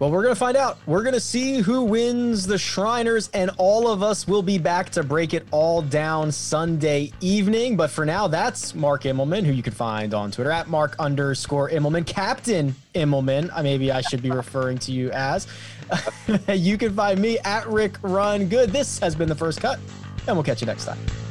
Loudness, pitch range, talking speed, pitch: -22 LUFS, 140-205 Hz, 210 wpm, 165 Hz